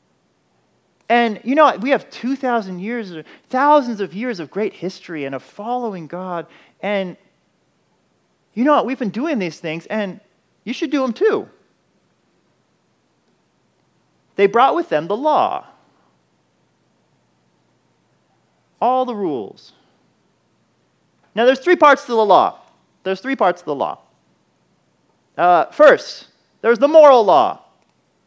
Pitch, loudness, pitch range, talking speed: 230 Hz, -17 LUFS, 185-265 Hz, 130 wpm